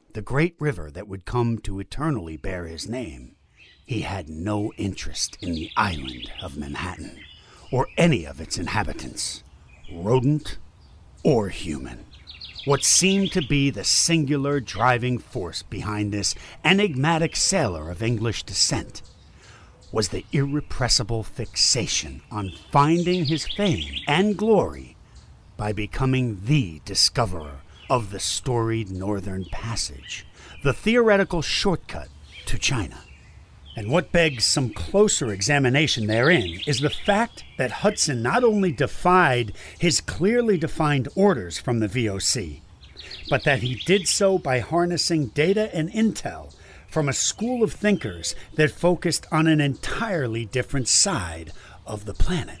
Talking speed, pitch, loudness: 130 wpm, 115 Hz, -23 LUFS